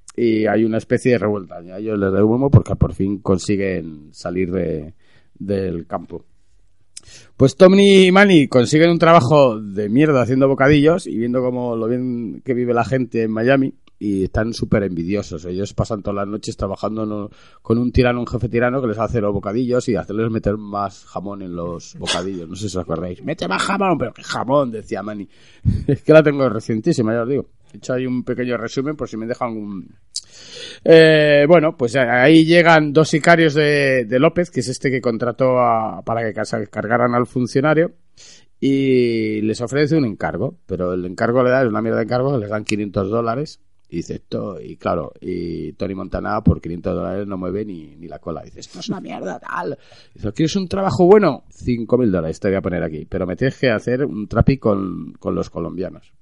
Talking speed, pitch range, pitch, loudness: 200 wpm, 100-130 Hz, 115 Hz, -18 LUFS